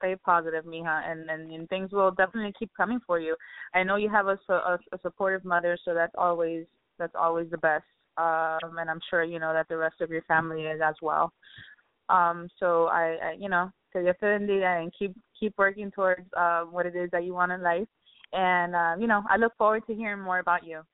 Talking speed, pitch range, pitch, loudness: 225 wpm, 165-195 Hz, 175 Hz, -27 LUFS